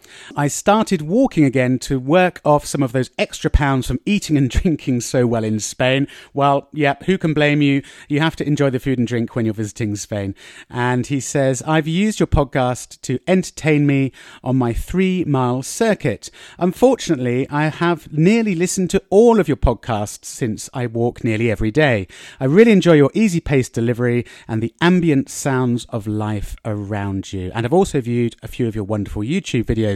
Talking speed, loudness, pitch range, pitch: 190 wpm, -18 LUFS, 120-165 Hz, 135 Hz